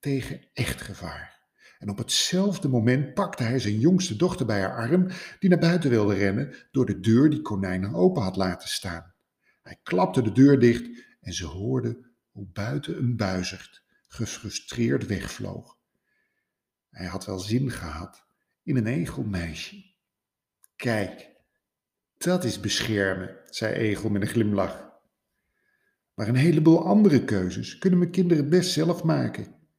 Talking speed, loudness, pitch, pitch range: 145 wpm, -25 LUFS, 120 Hz, 100-160 Hz